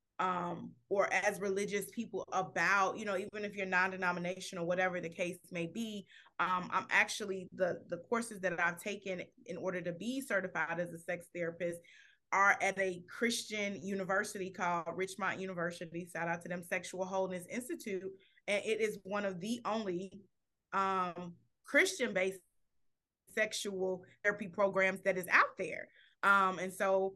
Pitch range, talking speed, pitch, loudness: 180-200 Hz, 160 wpm, 190 Hz, -35 LUFS